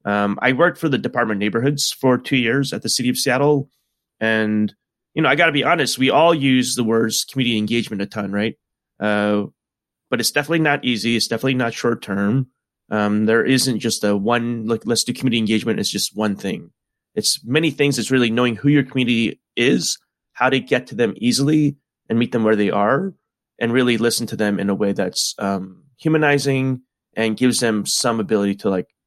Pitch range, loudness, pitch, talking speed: 110-130 Hz, -19 LUFS, 120 Hz, 205 wpm